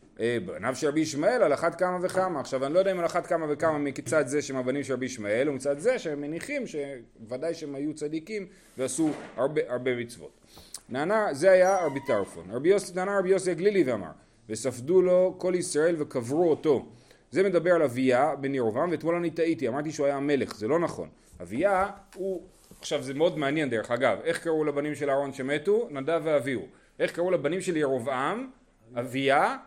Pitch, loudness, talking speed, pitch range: 150 Hz, -27 LUFS, 180 wpm, 135-180 Hz